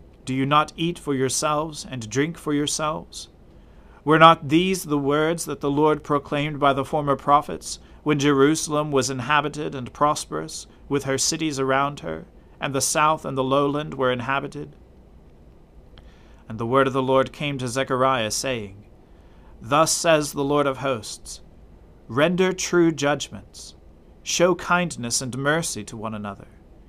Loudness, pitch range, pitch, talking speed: -22 LUFS, 120-150 Hz, 140 Hz, 150 wpm